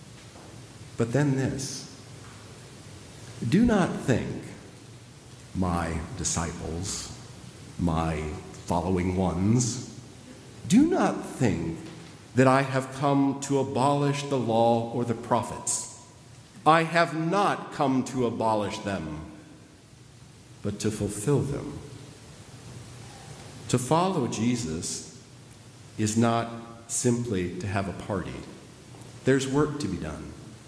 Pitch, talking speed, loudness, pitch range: 120 Hz, 100 wpm, -27 LUFS, 105-135 Hz